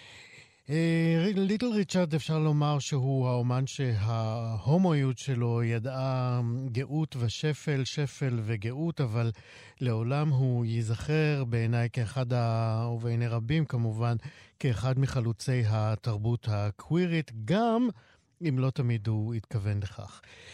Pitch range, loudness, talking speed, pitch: 115-150 Hz, -29 LUFS, 100 wpm, 125 Hz